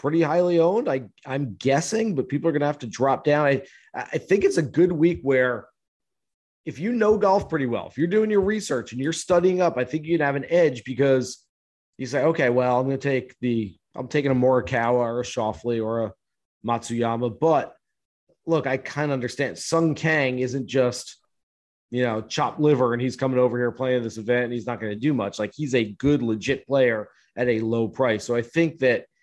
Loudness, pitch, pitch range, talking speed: -23 LUFS, 130 Hz, 120-155 Hz, 215 wpm